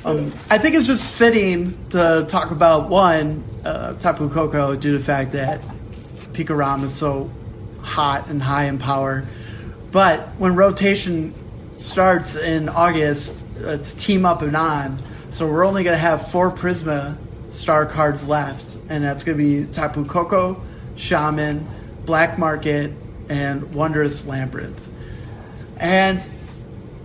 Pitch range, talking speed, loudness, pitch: 140-170 Hz, 140 wpm, -19 LUFS, 150 Hz